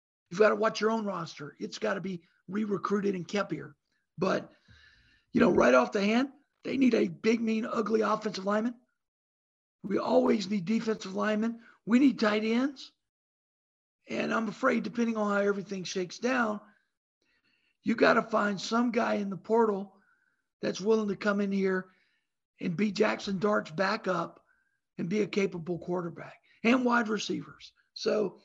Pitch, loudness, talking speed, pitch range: 210 Hz, -29 LUFS, 165 wpm, 195-230 Hz